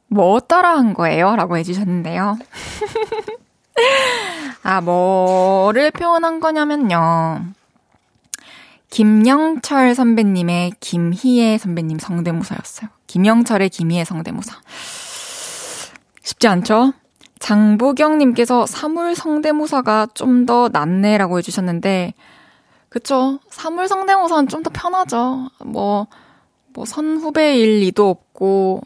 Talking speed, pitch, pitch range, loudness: 225 characters per minute, 235 Hz, 190-305 Hz, -16 LUFS